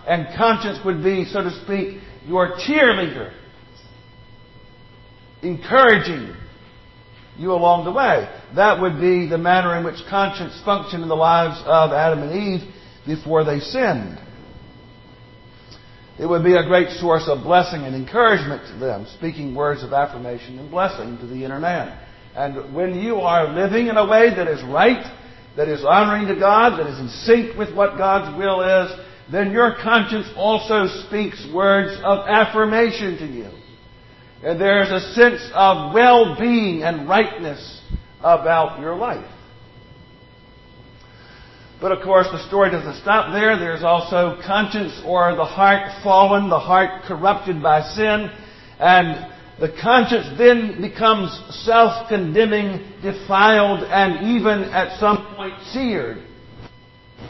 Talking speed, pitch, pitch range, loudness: 140 wpm, 180 Hz, 150-200 Hz, -18 LUFS